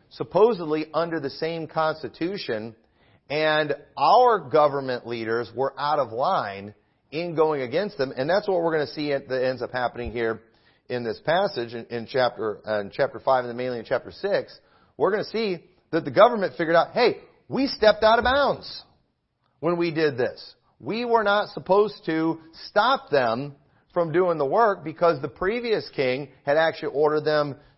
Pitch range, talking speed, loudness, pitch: 125-180 Hz, 175 wpm, -24 LUFS, 155 Hz